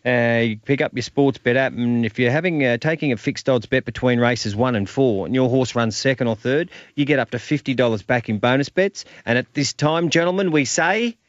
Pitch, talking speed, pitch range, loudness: 130 Hz, 250 wpm, 120-145 Hz, -20 LUFS